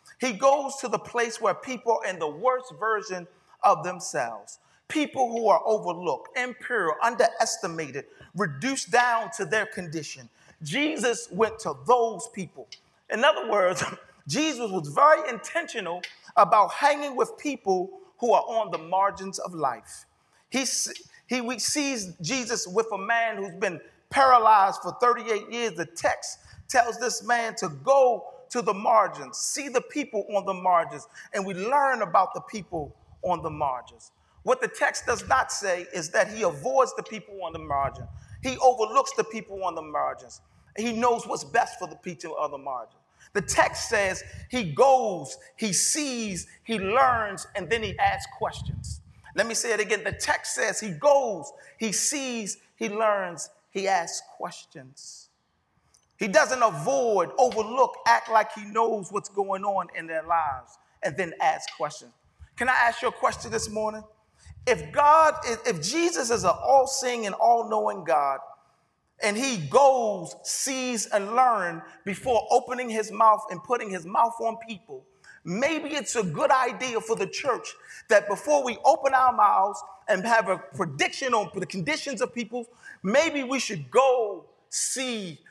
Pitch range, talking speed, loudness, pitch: 195-260 Hz, 165 wpm, -25 LUFS, 225 Hz